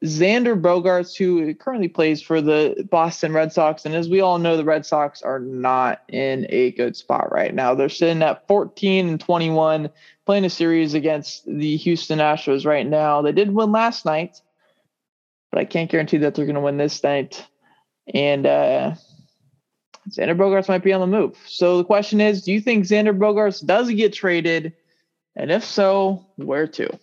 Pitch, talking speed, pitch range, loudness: 165 Hz, 185 wpm, 150-190 Hz, -19 LUFS